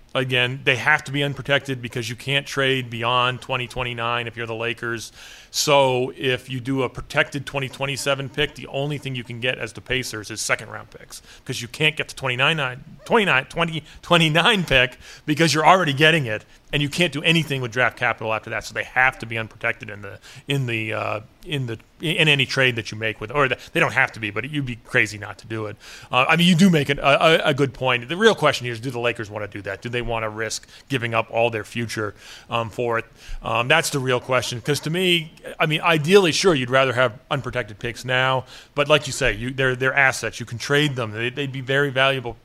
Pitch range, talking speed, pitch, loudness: 115-145 Hz, 240 wpm, 130 Hz, -21 LUFS